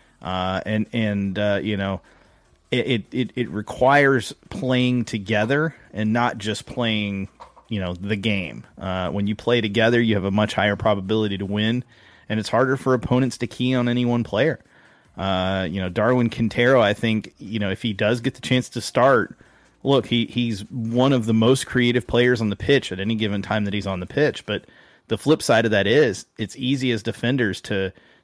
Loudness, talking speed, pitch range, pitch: -22 LUFS, 200 wpm, 100-125 Hz, 110 Hz